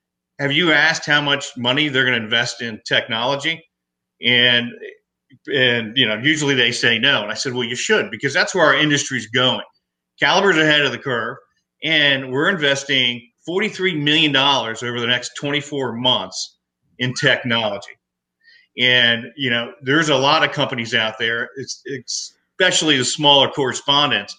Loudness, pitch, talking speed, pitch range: -17 LUFS, 130 Hz, 165 wpm, 120-145 Hz